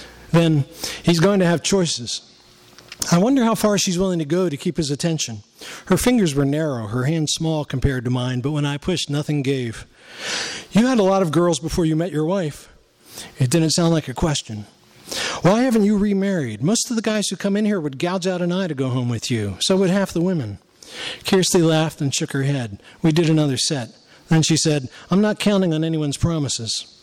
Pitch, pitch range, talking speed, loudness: 165 Hz, 140-190 Hz, 215 wpm, -20 LUFS